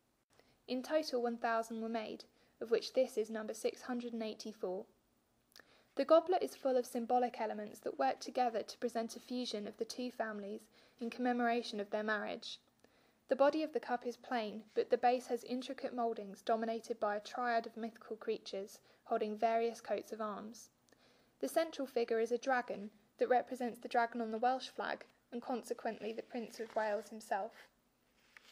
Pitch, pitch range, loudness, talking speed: 235 Hz, 220-250 Hz, -38 LUFS, 170 wpm